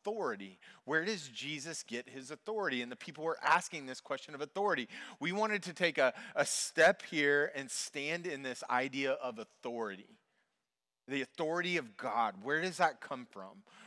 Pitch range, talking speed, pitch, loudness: 130-175 Hz, 175 wpm, 150 Hz, -35 LUFS